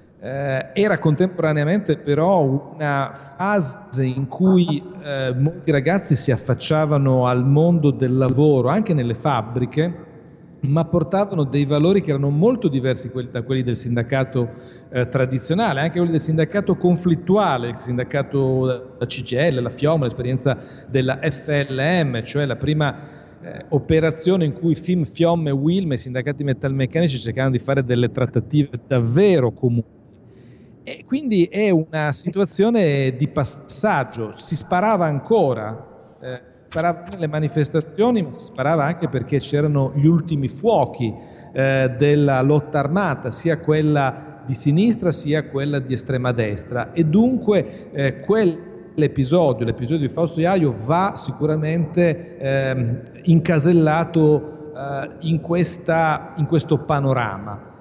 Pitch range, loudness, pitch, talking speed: 130-165 Hz, -20 LUFS, 150 Hz, 130 wpm